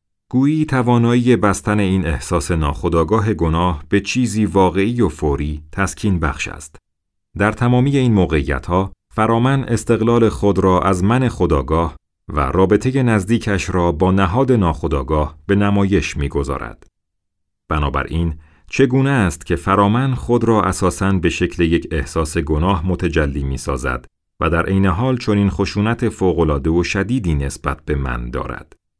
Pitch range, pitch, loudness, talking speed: 80-110 Hz, 95 Hz, -17 LUFS, 140 wpm